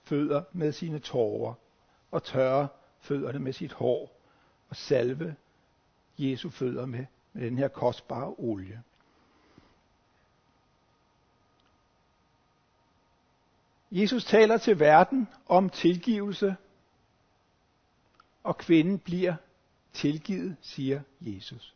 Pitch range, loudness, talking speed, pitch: 130-180 Hz, -28 LUFS, 90 wpm, 150 Hz